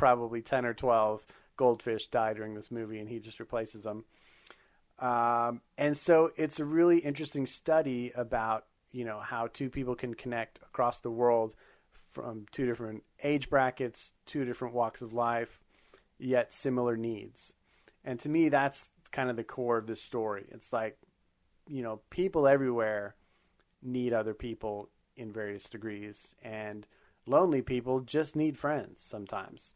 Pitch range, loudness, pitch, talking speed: 110-135 Hz, -32 LUFS, 120 Hz, 155 wpm